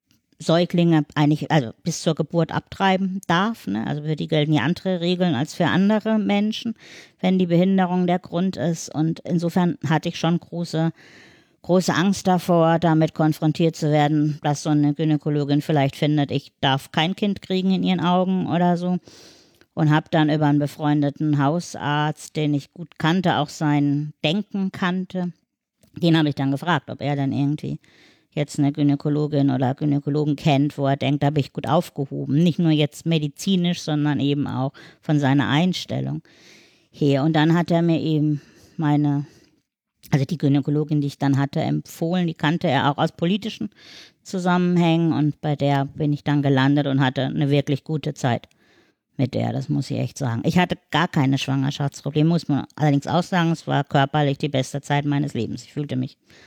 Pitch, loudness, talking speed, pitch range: 150 Hz, -21 LUFS, 175 wpm, 145-170 Hz